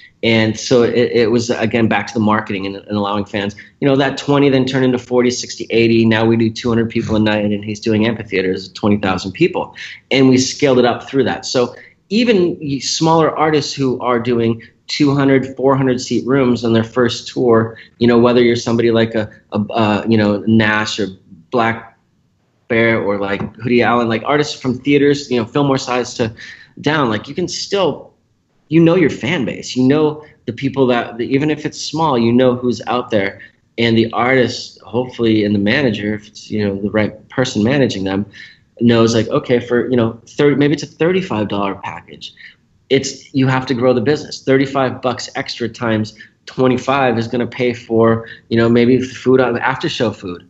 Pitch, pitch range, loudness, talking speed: 120 Hz, 110-135 Hz, -15 LUFS, 200 wpm